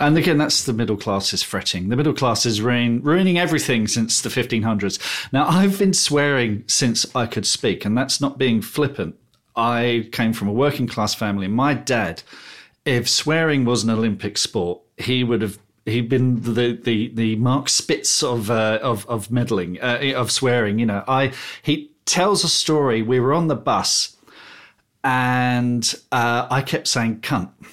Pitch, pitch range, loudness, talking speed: 120 Hz, 115-135 Hz, -20 LUFS, 175 wpm